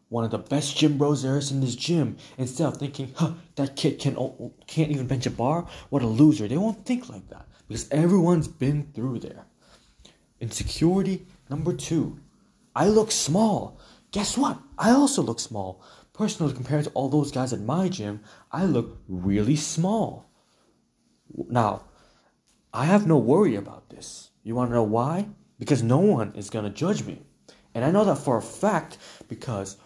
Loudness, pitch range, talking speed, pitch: -25 LUFS, 120-165 Hz, 175 wpm, 145 Hz